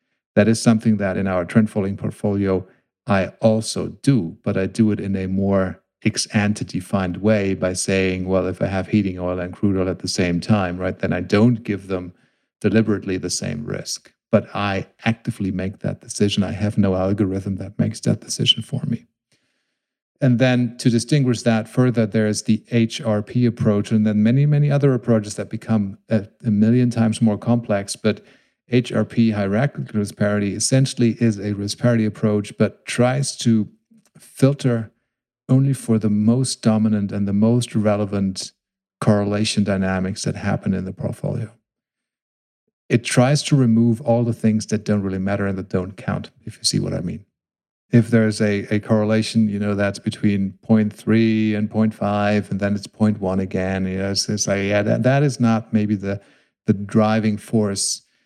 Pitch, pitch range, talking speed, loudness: 105 Hz, 100-115 Hz, 175 wpm, -20 LUFS